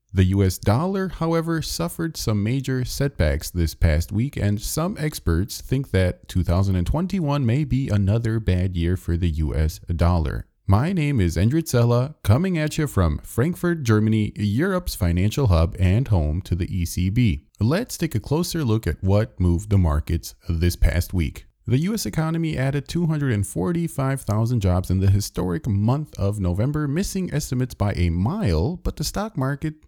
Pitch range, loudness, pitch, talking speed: 90-145 Hz, -23 LUFS, 105 Hz, 160 wpm